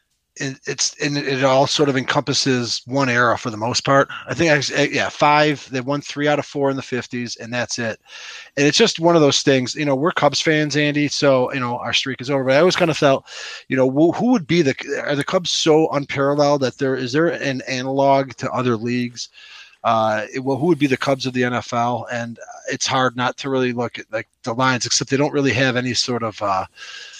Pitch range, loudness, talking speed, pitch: 125-145 Hz, -19 LUFS, 235 wpm, 135 Hz